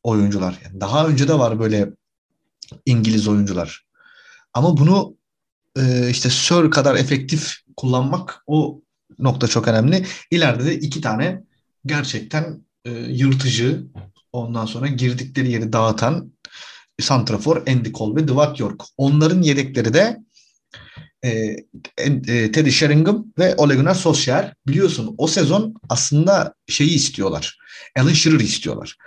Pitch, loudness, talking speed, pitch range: 140 Hz, -18 LUFS, 120 wpm, 115-155 Hz